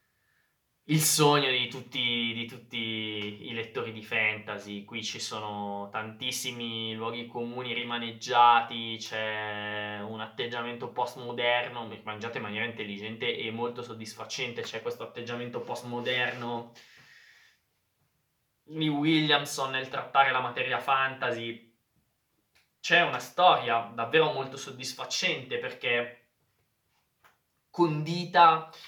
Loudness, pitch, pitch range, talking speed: -29 LUFS, 120 Hz, 110-130 Hz, 100 wpm